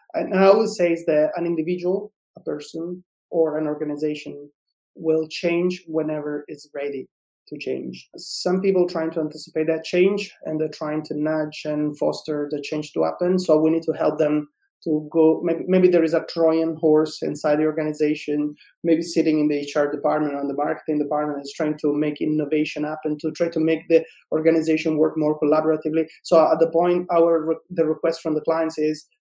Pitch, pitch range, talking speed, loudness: 155 Hz, 150-165 Hz, 190 wpm, -22 LUFS